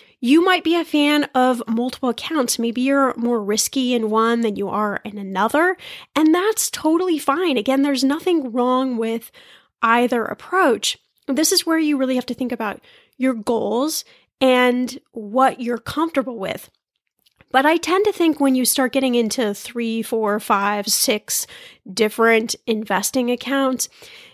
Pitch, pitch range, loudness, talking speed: 255 Hz, 230-295 Hz, -19 LUFS, 155 wpm